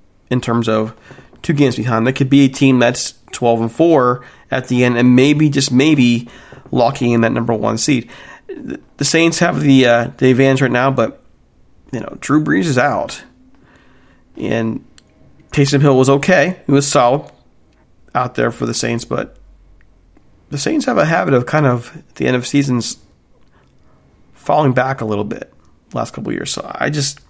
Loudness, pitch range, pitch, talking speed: -14 LUFS, 120-140 Hz, 130 Hz, 180 wpm